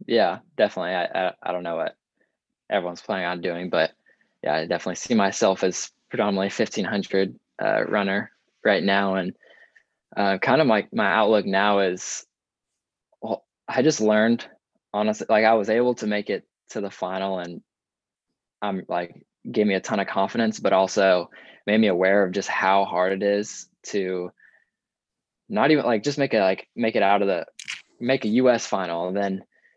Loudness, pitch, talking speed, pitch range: -23 LUFS, 100 Hz, 180 wpm, 95-110 Hz